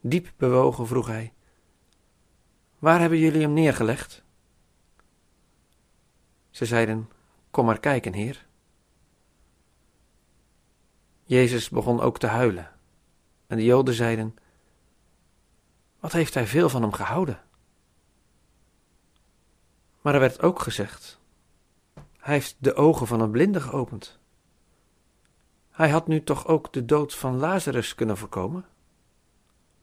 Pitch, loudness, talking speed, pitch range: 115 Hz, -24 LUFS, 110 wpm, 90-140 Hz